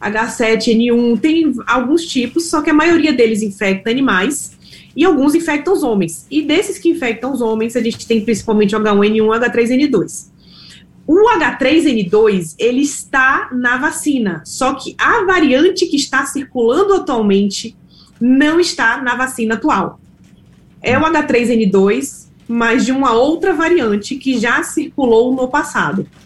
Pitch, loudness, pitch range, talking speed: 255 Hz, -14 LUFS, 230-310 Hz, 150 wpm